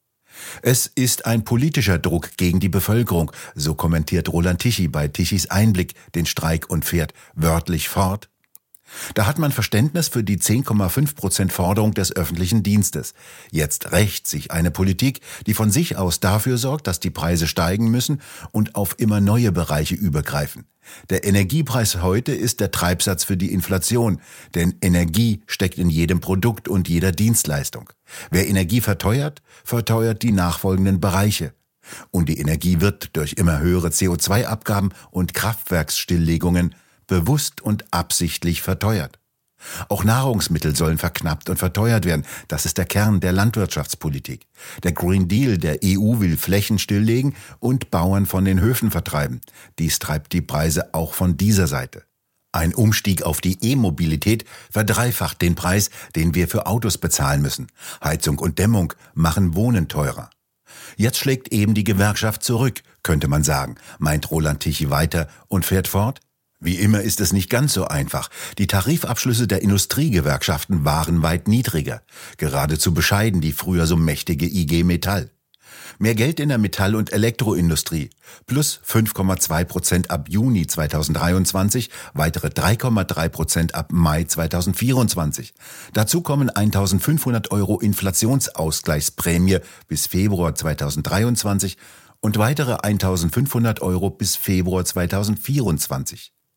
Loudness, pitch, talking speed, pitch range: -20 LUFS, 95 Hz, 135 wpm, 85-110 Hz